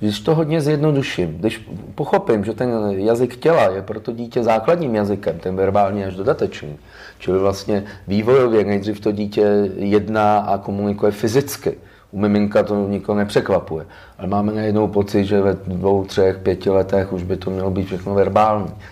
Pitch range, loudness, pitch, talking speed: 95-110 Hz, -19 LUFS, 105 Hz, 165 wpm